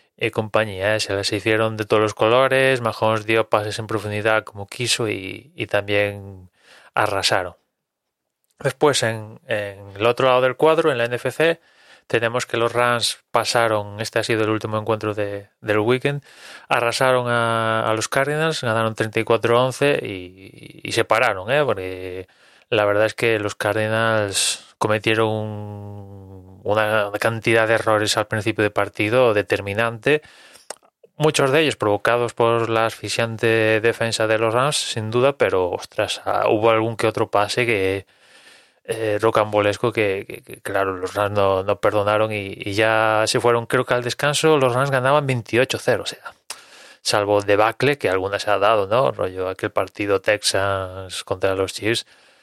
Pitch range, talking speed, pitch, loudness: 105-120 Hz, 160 wpm, 110 Hz, -20 LUFS